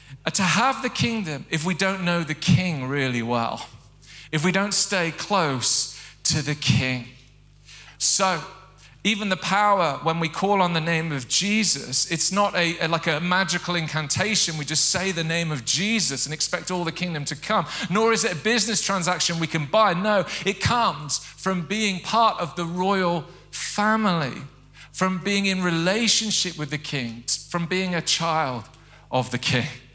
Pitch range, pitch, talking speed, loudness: 145-190 Hz, 170 Hz, 170 wpm, -22 LUFS